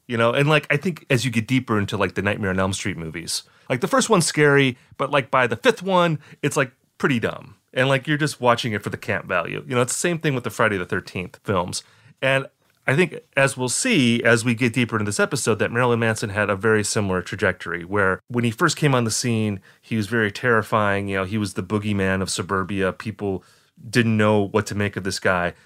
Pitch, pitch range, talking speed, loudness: 120 Hz, 105-135 Hz, 245 wpm, -21 LUFS